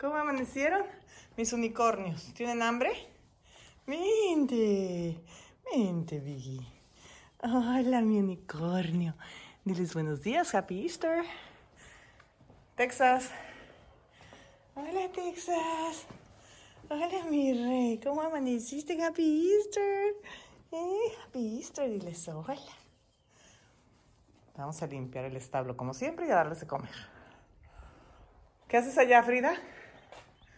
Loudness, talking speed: -32 LUFS, 90 wpm